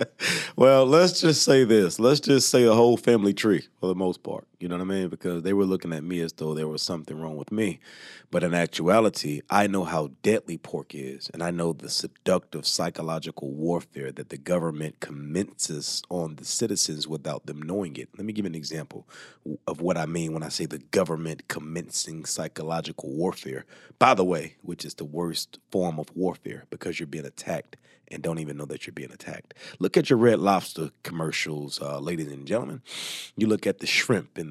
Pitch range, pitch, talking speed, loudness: 80-95 Hz, 85 Hz, 205 wpm, -25 LUFS